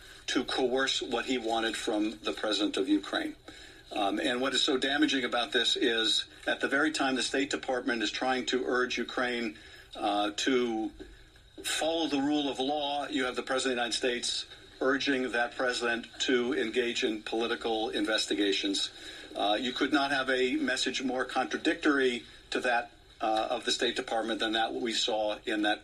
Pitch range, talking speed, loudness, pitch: 120-145 Hz, 175 wpm, -30 LUFS, 130 Hz